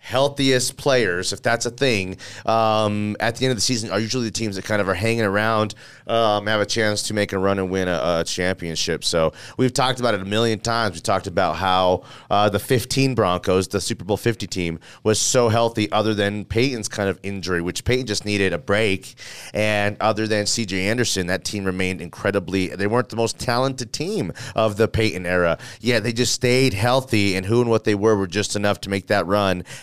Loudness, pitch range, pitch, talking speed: -21 LUFS, 95-115 Hz, 105 Hz, 220 wpm